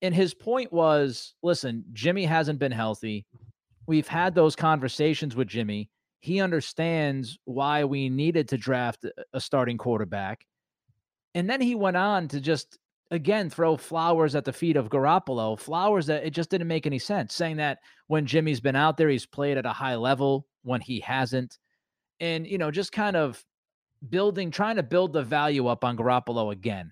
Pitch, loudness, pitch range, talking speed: 150 Hz, -26 LUFS, 125-170 Hz, 180 wpm